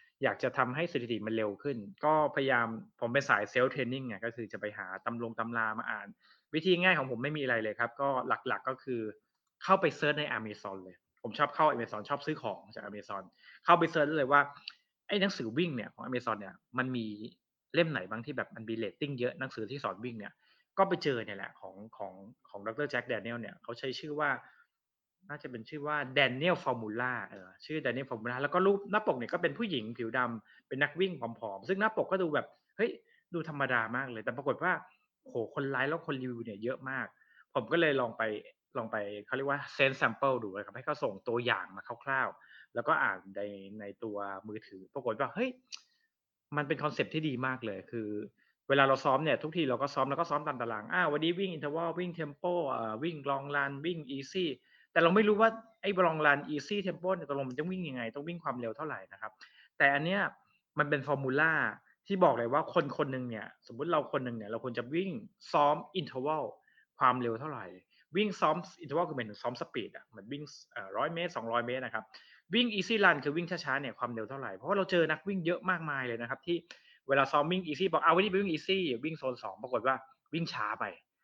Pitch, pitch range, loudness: 140 Hz, 115-165 Hz, -33 LUFS